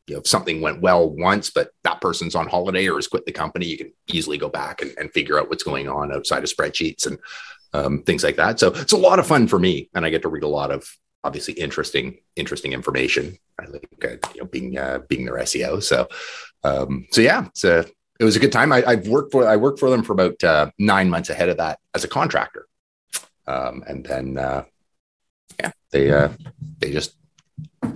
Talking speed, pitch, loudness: 220 wpm, 120 Hz, -20 LUFS